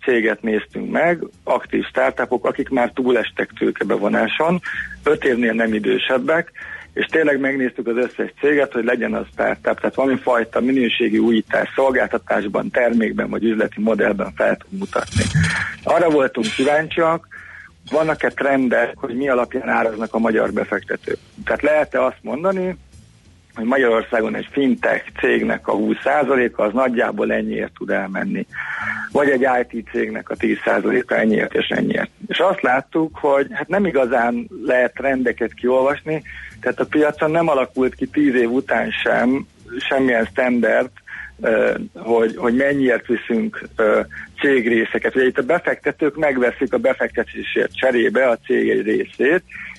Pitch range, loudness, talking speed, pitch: 115-150 Hz, -19 LUFS, 135 wpm, 130 Hz